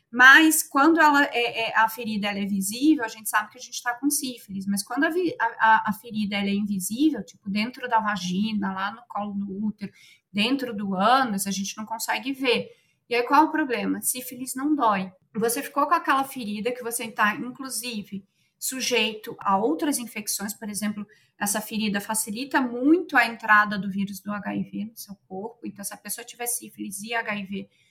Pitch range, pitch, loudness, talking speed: 200-250 Hz, 220 Hz, -24 LUFS, 195 wpm